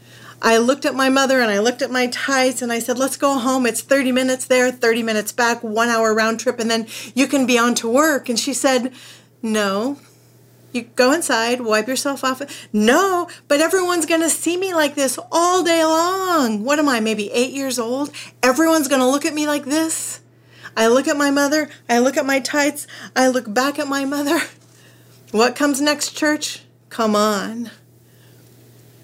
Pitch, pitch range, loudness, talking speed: 265 Hz, 235-295 Hz, -18 LUFS, 195 wpm